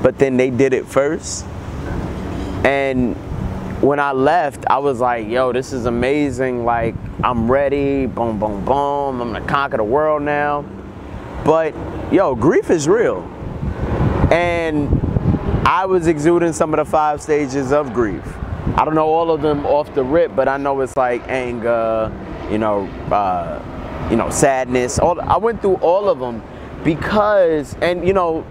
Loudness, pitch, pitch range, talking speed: -17 LUFS, 135 Hz, 115-155 Hz, 160 wpm